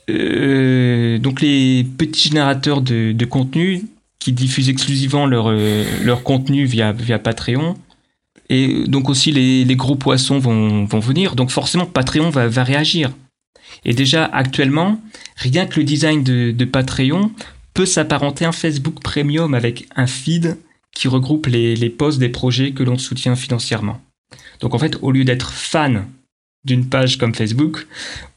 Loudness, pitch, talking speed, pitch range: -16 LUFS, 135 Hz, 160 wpm, 125-150 Hz